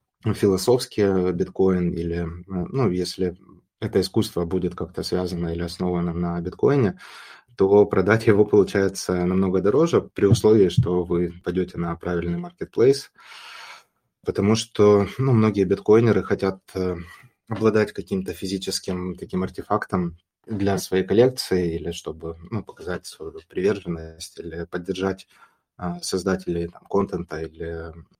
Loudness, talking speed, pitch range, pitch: -23 LUFS, 115 wpm, 85-100 Hz, 95 Hz